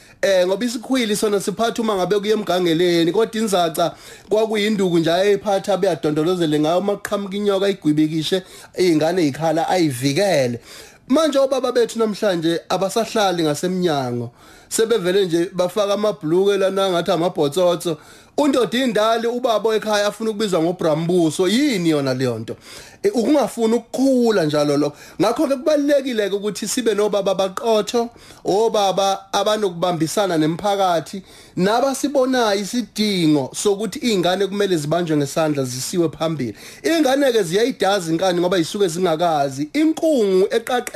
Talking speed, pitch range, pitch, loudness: 115 wpm, 170-225 Hz, 195 Hz, -19 LUFS